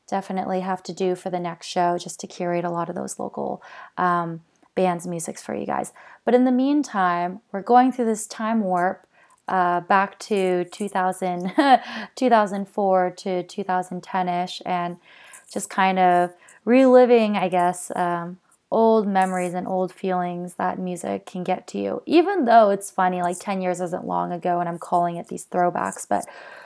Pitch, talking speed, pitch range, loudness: 185 Hz, 170 wpm, 175-205 Hz, -22 LUFS